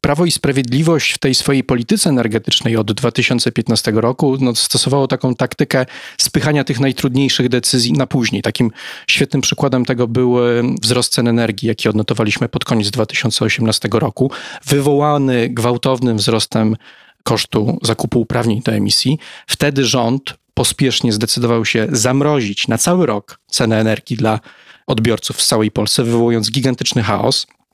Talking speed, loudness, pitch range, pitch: 135 wpm, -15 LUFS, 115-135 Hz, 125 Hz